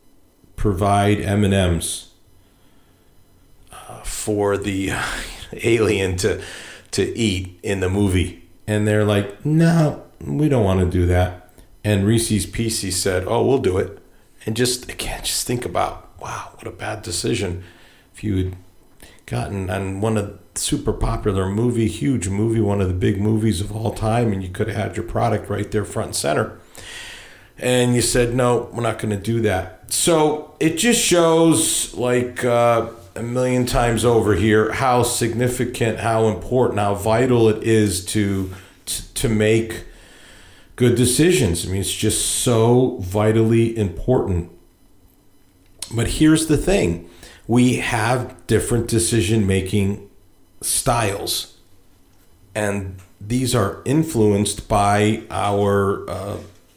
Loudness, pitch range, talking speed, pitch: -19 LUFS, 95-120 Hz, 140 wpm, 105 Hz